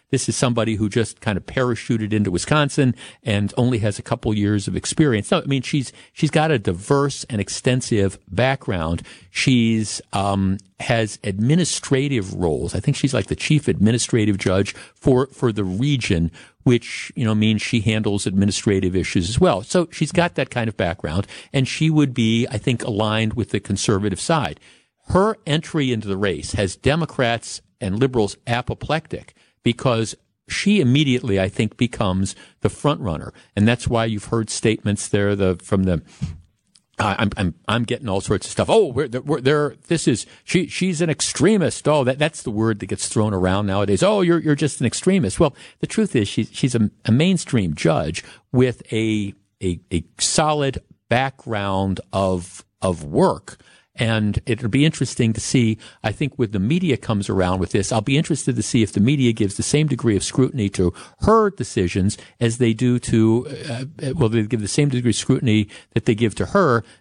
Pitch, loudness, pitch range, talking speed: 115 Hz, -20 LUFS, 100-135 Hz, 185 wpm